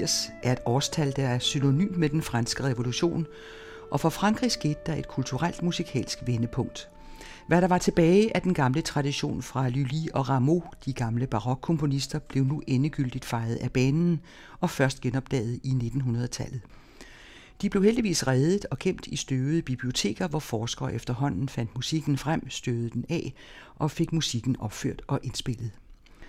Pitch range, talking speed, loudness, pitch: 125-160 Hz, 160 wpm, -28 LUFS, 135 Hz